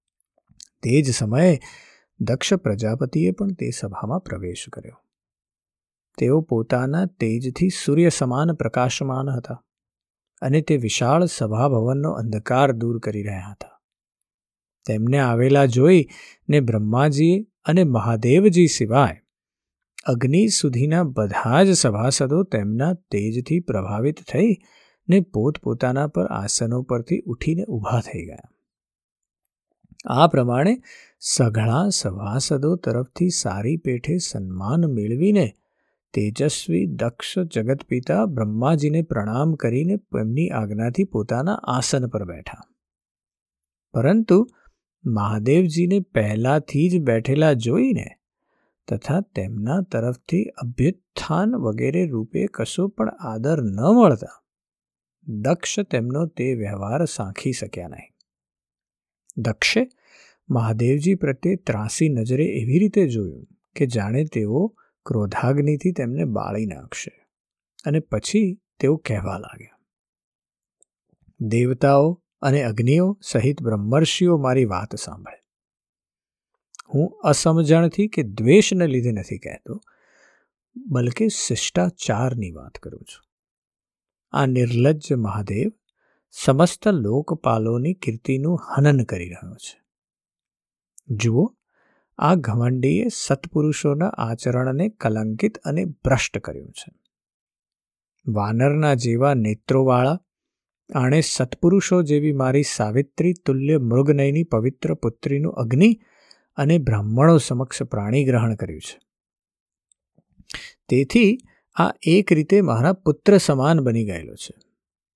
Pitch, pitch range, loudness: 135 Hz, 115-165 Hz, -21 LUFS